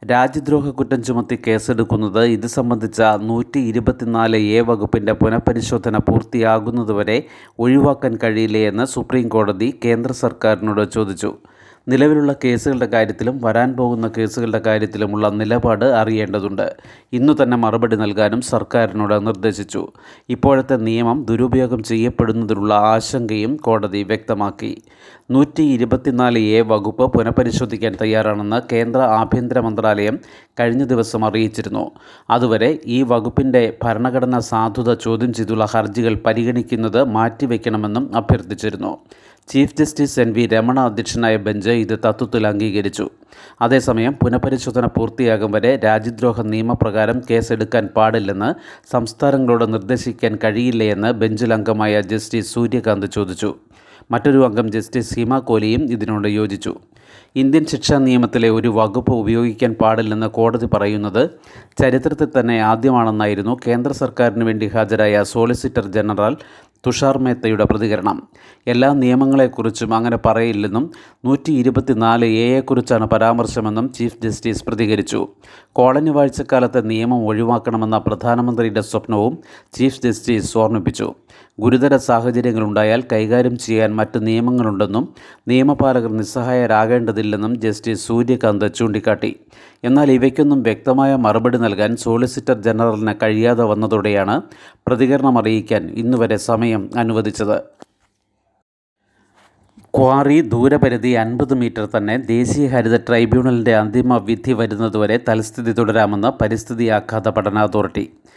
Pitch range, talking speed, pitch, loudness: 110-125 Hz, 100 wpm, 115 Hz, -17 LUFS